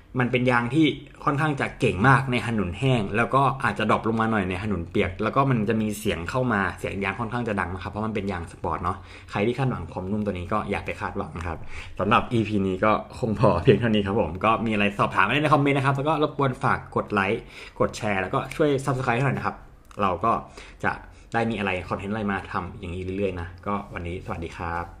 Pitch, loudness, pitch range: 105 Hz, -25 LUFS, 95-120 Hz